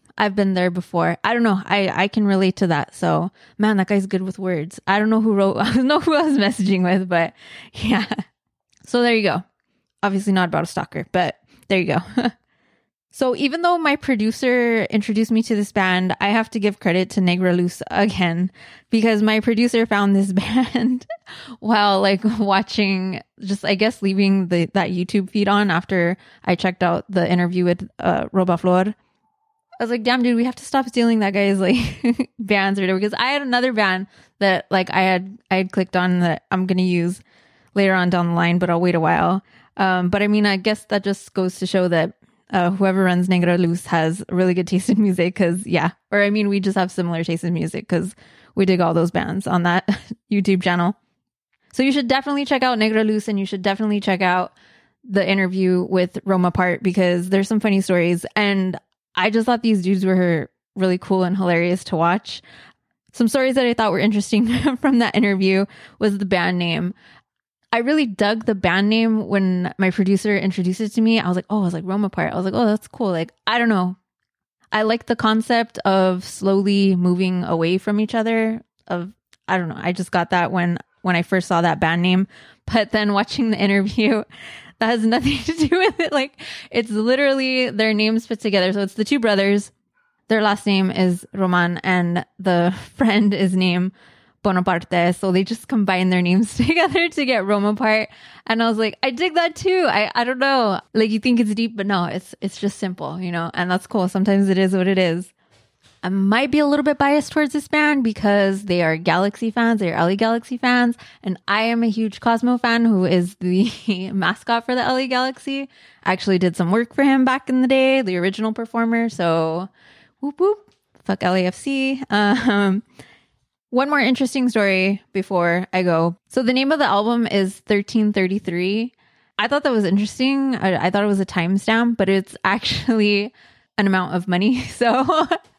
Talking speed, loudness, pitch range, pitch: 205 wpm, -19 LUFS, 185-230 Hz, 200 Hz